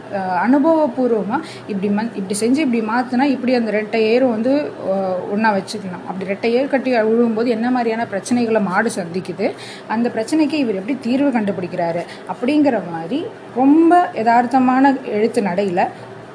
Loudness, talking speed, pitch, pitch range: -18 LUFS, 130 wpm, 230 Hz, 205-260 Hz